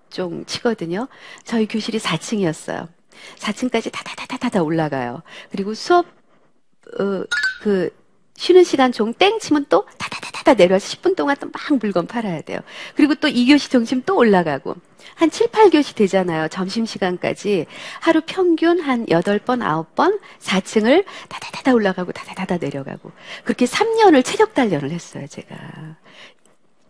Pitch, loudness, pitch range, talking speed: 230 Hz, -18 LUFS, 185-300 Hz, 290 characters per minute